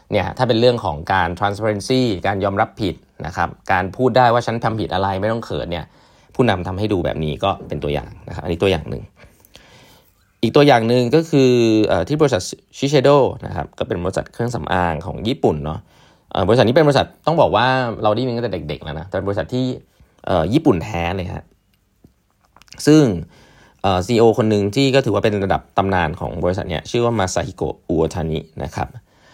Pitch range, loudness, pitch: 85-120 Hz, -18 LUFS, 100 Hz